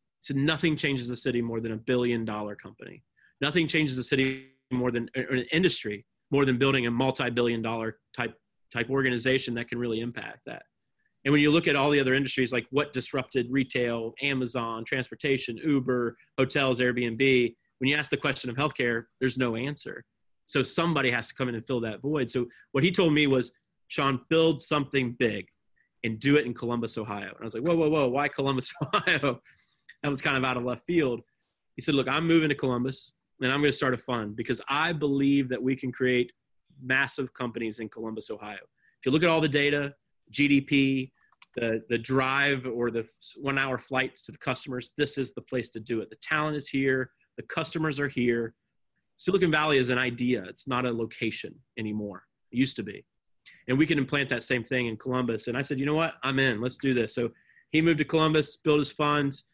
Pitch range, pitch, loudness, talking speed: 120-140 Hz, 130 Hz, -27 LUFS, 210 wpm